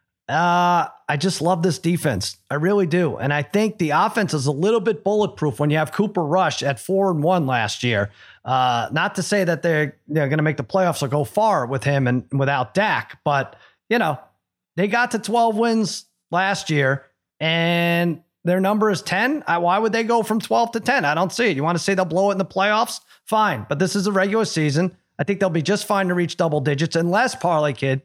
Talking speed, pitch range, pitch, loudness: 230 wpm, 150-200 Hz, 175 Hz, -20 LUFS